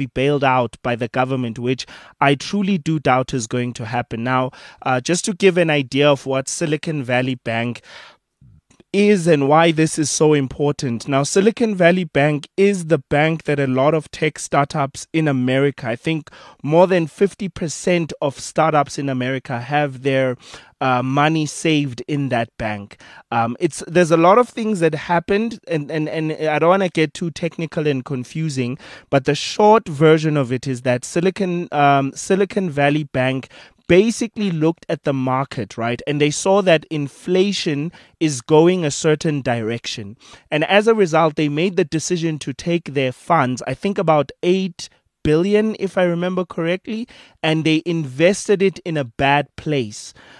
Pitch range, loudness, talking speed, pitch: 135-175 Hz, -18 LUFS, 175 wpm, 155 Hz